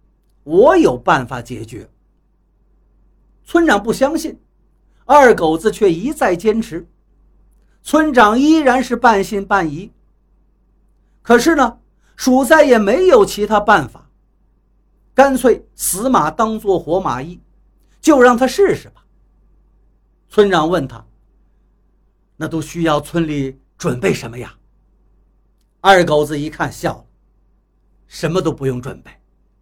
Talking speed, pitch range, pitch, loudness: 170 characters per minute, 155-255 Hz, 200 Hz, -14 LUFS